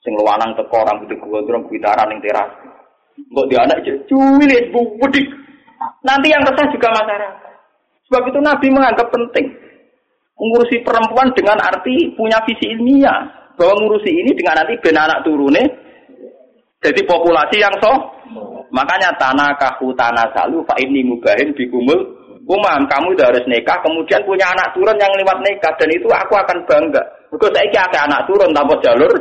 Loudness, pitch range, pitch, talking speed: -13 LUFS, 185-275 Hz, 235 Hz, 155 wpm